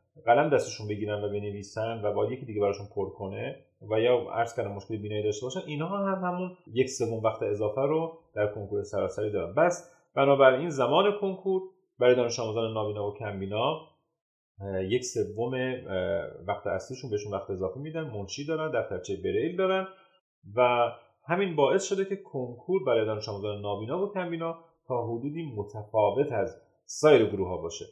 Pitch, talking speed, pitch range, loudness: 125 Hz, 170 wpm, 105-165 Hz, -29 LUFS